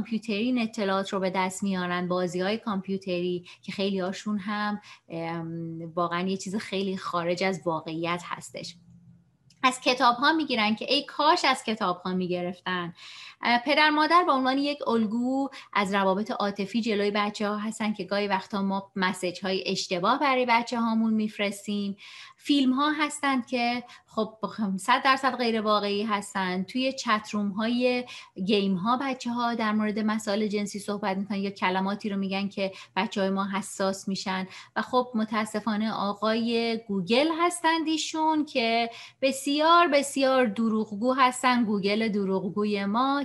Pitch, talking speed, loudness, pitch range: 210 Hz, 145 wpm, -27 LUFS, 195-245 Hz